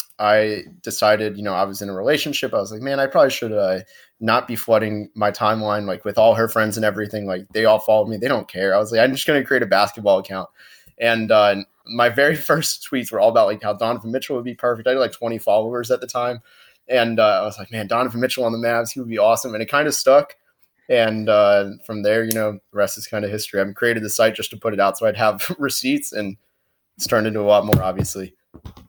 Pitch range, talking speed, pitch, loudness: 105-120 Hz, 260 wpm, 110 Hz, -19 LUFS